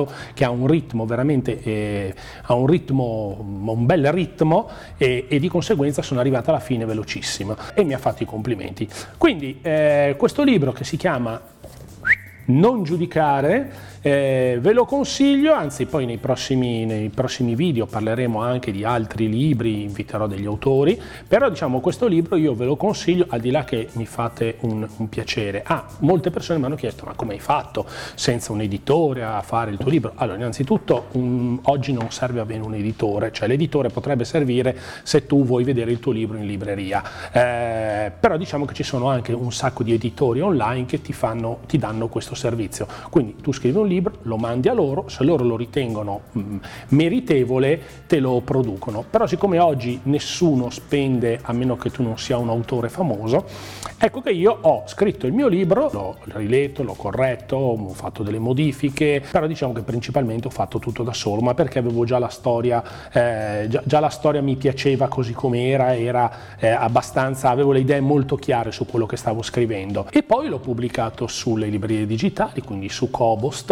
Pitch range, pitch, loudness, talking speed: 115-145 Hz, 125 Hz, -21 LUFS, 185 wpm